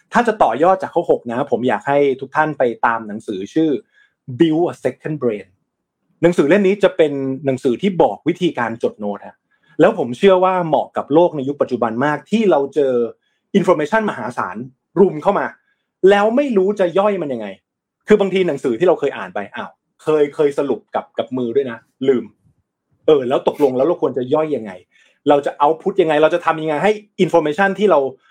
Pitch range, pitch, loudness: 145-195 Hz, 170 Hz, -17 LUFS